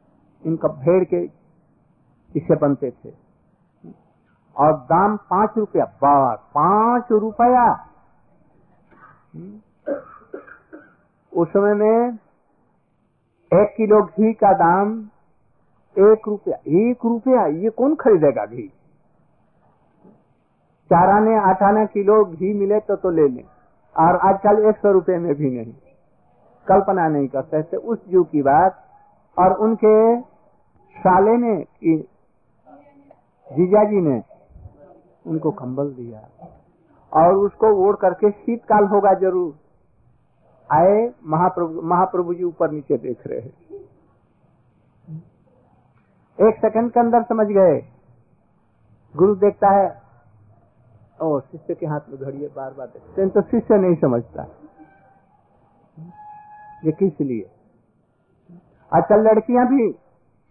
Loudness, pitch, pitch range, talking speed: -18 LUFS, 190 Hz, 155-215 Hz, 105 wpm